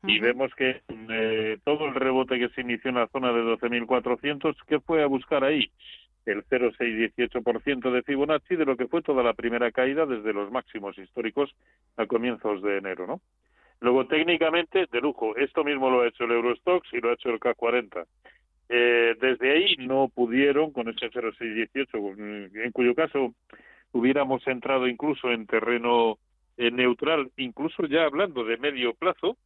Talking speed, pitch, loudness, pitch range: 165 wpm, 125 Hz, -26 LUFS, 115-140 Hz